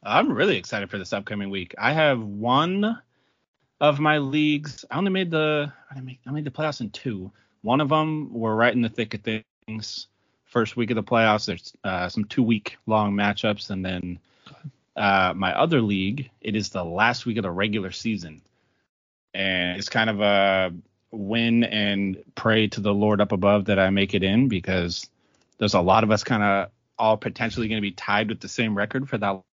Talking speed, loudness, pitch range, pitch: 205 wpm, -23 LUFS, 100-120 Hz, 110 Hz